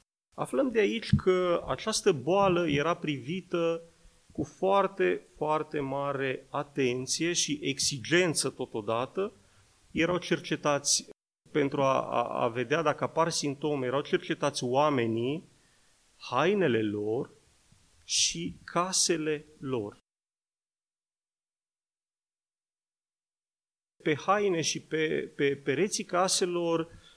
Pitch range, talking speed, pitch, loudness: 140-175 Hz, 90 wpm, 155 Hz, -29 LUFS